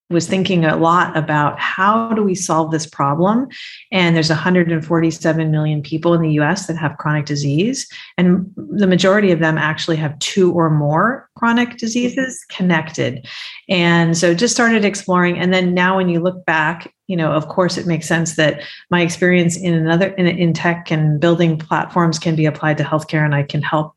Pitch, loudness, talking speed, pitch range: 170 Hz, -16 LUFS, 185 wpm, 155-185 Hz